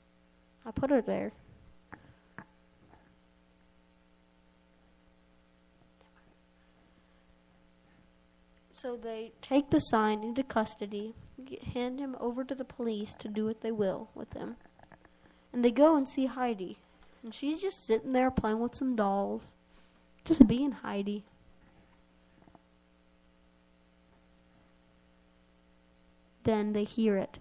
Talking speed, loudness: 100 wpm, -31 LUFS